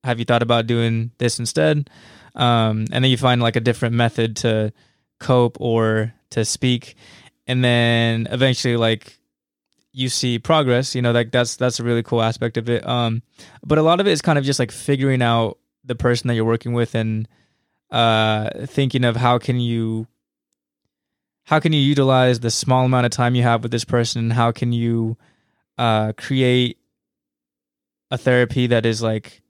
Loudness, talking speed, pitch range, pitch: -19 LUFS, 185 wpm, 115-125 Hz, 120 Hz